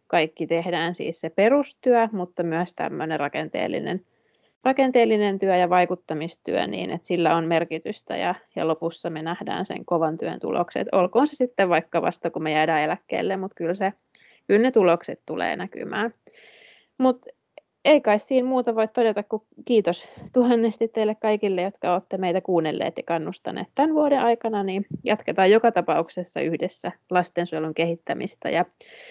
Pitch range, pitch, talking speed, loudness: 170-230 Hz, 190 Hz, 150 wpm, -24 LUFS